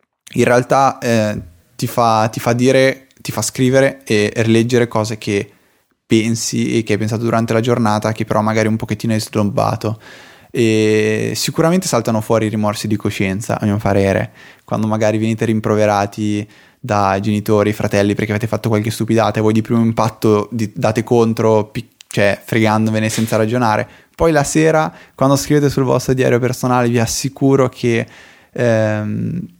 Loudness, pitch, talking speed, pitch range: -16 LUFS, 110 Hz, 155 wpm, 105-120 Hz